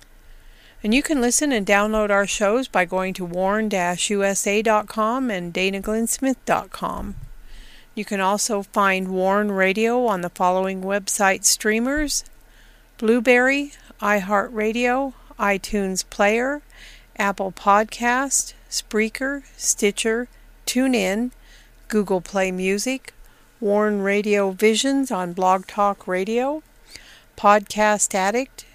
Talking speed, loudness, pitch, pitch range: 95 wpm, -21 LUFS, 210 Hz, 195-240 Hz